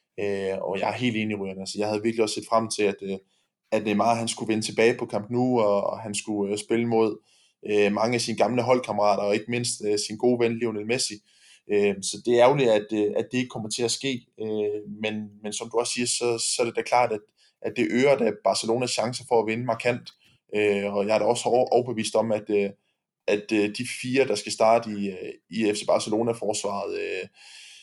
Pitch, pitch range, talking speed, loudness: 110 Hz, 105-120 Hz, 235 wpm, -25 LUFS